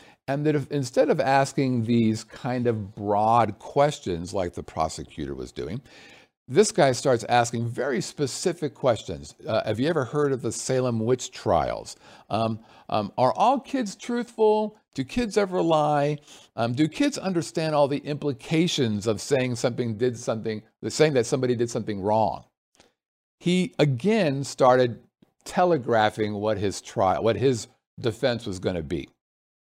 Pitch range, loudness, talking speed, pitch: 110-150 Hz, -25 LUFS, 155 wpm, 130 Hz